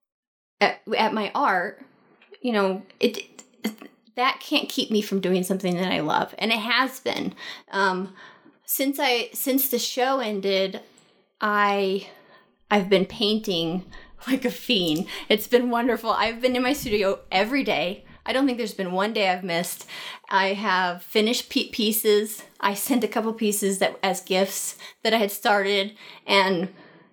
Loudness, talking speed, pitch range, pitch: -24 LUFS, 160 wpm, 195-245 Hz, 210 Hz